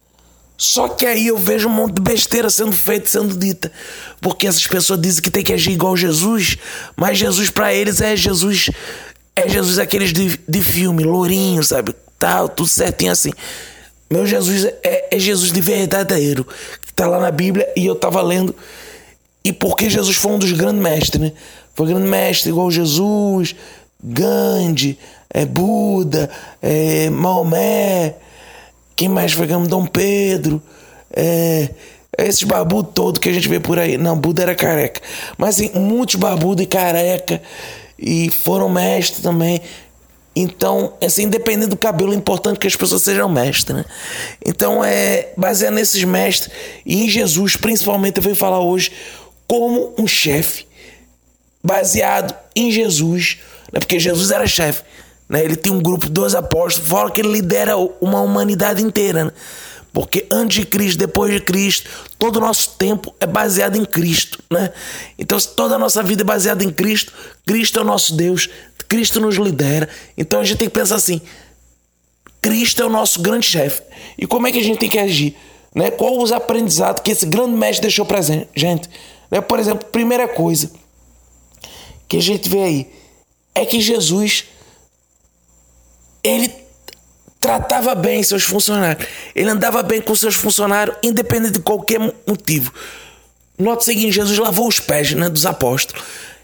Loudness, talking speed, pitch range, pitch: -15 LUFS, 165 wpm, 165-215 Hz, 190 Hz